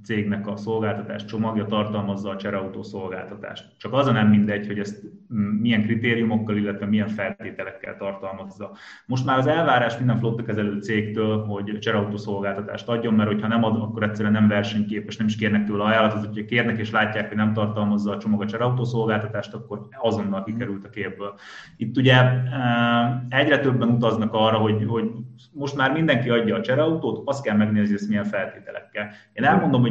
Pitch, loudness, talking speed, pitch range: 110 Hz, -23 LUFS, 170 wpm, 105-115 Hz